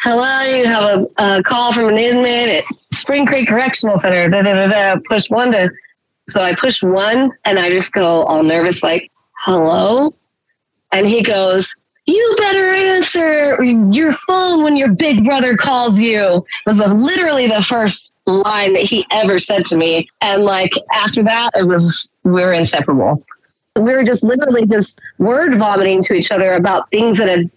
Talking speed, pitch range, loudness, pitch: 180 wpm, 190-255 Hz, -13 LUFS, 215 Hz